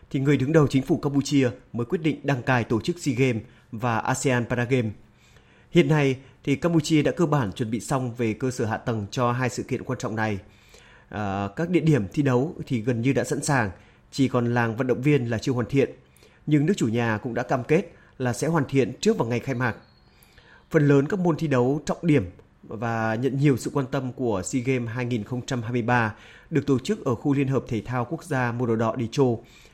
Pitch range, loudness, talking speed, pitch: 120-145 Hz, -24 LUFS, 230 wpm, 130 Hz